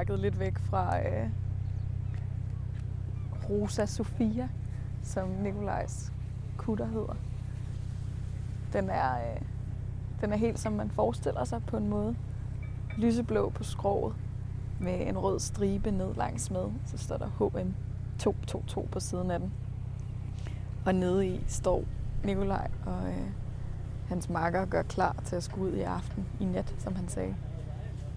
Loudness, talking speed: -33 LUFS, 135 wpm